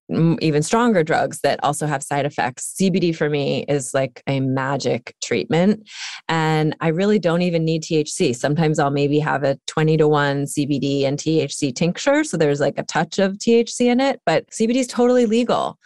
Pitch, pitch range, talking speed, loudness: 155 Hz, 145-195 Hz, 185 wpm, -19 LUFS